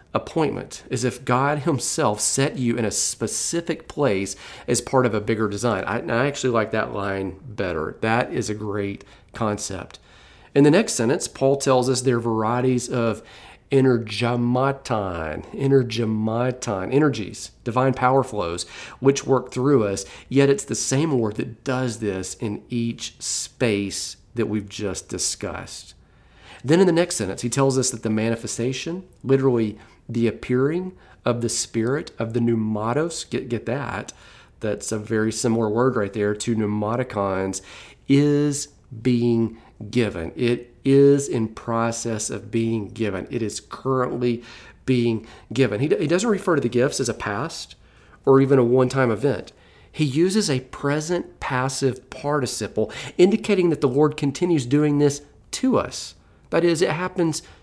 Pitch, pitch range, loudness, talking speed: 120 Hz, 110-135 Hz, -22 LUFS, 155 wpm